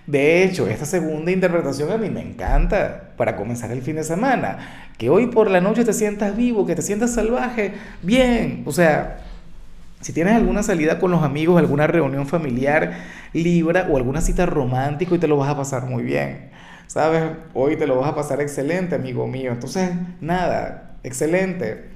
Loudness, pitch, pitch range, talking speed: -20 LUFS, 170 Hz, 145-190 Hz, 180 wpm